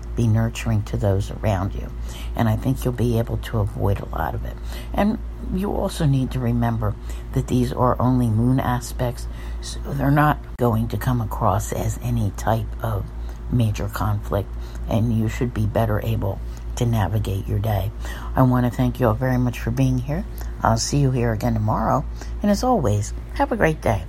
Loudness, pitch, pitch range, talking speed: -22 LUFS, 115 Hz, 100-125 Hz, 190 wpm